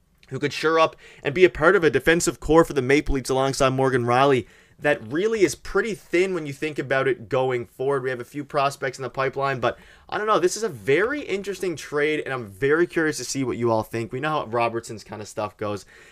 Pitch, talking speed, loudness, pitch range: 140 Hz, 250 wpm, -23 LUFS, 125-165 Hz